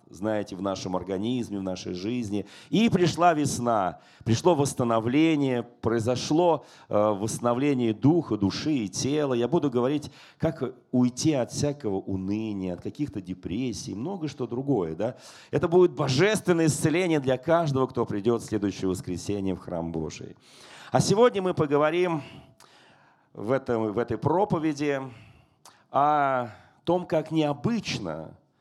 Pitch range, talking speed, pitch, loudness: 110-155 Hz, 125 wpm, 130 Hz, -26 LUFS